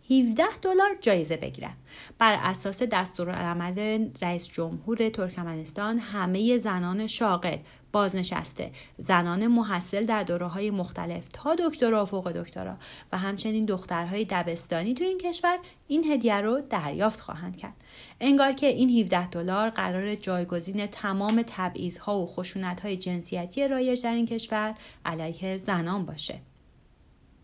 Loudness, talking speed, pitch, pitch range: -27 LUFS, 130 wpm, 200 Hz, 180-230 Hz